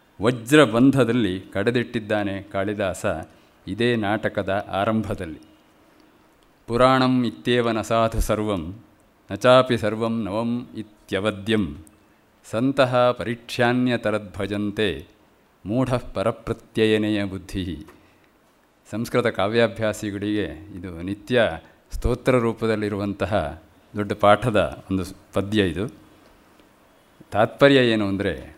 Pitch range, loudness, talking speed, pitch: 100-120 Hz, -22 LUFS, 75 wpm, 110 Hz